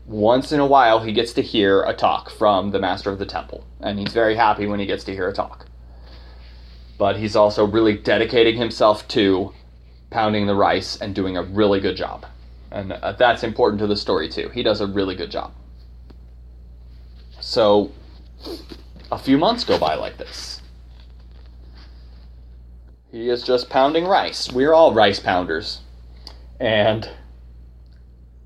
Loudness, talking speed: -19 LUFS, 155 wpm